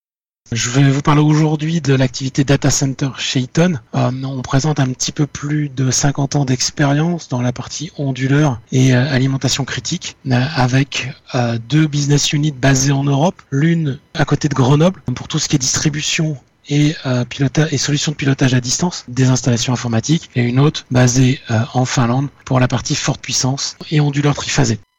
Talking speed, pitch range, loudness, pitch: 185 wpm, 130-150 Hz, -16 LUFS, 135 Hz